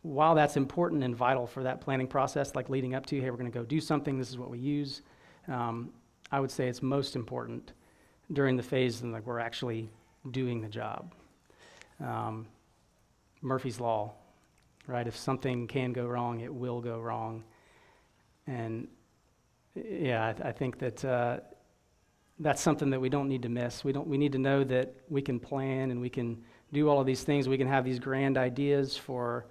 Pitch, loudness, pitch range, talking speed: 130 Hz, -32 LUFS, 120-135 Hz, 195 wpm